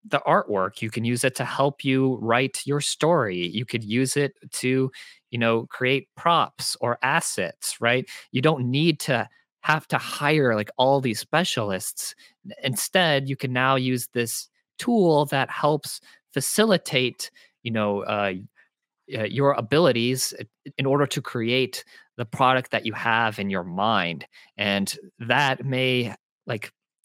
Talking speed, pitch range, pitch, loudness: 150 wpm, 115-140 Hz, 130 Hz, -24 LUFS